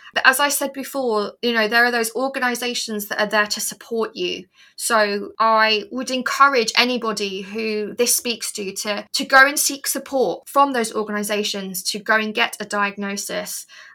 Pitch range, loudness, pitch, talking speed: 210-260 Hz, -19 LUFS, 225 Hz, 175 wpm